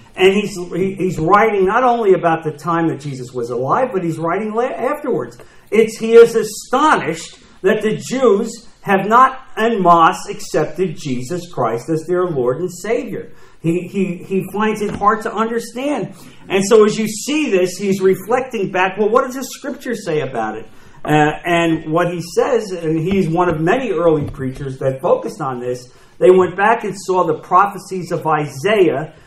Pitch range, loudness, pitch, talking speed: 165-215 Hz, -16 LUFS, 185 Hz, 180 wpm